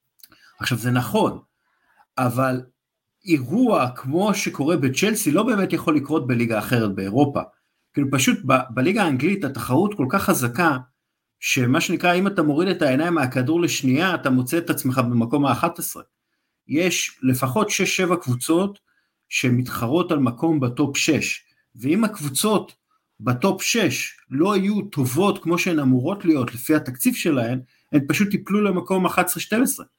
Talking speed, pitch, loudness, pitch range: 135 wpm, 155 Hz, -21 LUFS, 130-185 Hz